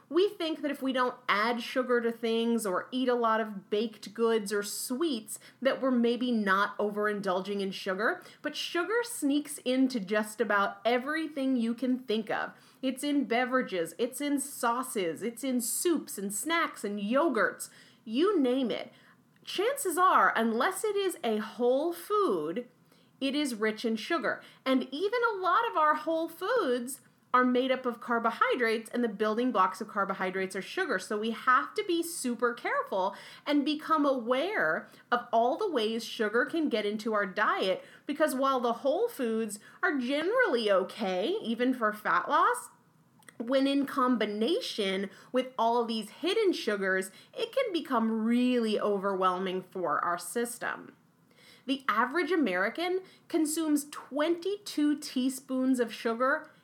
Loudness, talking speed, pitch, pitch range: -30 LUFS, 150 wpm, 245 Hz, 220-295 Hz